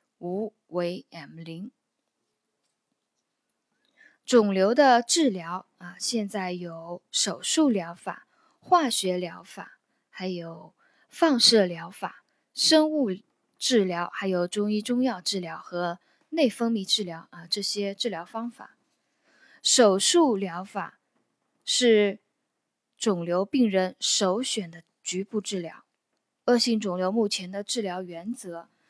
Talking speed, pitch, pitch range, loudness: 165 characters per minute, 200 Hz, 180-235 Hz, -25 LUFS